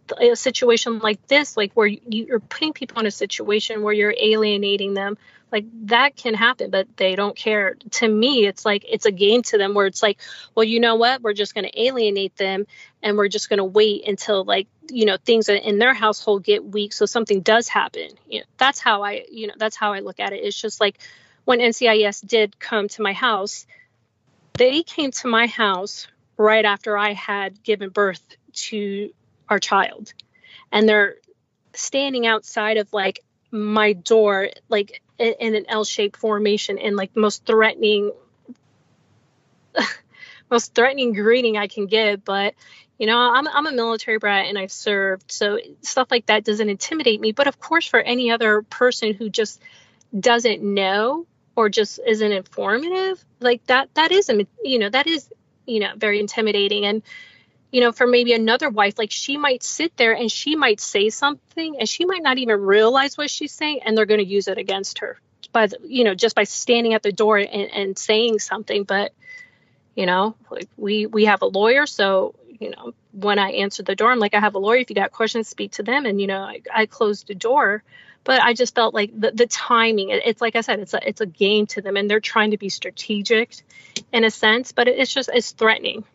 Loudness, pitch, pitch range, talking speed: -19 LUFS, 220 Hz, 205-240 Hz, 200 wpm